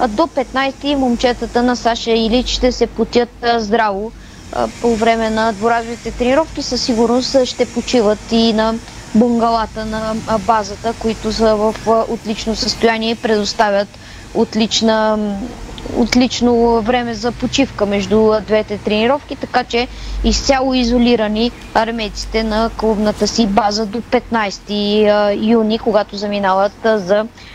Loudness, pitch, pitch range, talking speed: -16 LUFS, 230 Hz, 220-240 Hz, 120 wpm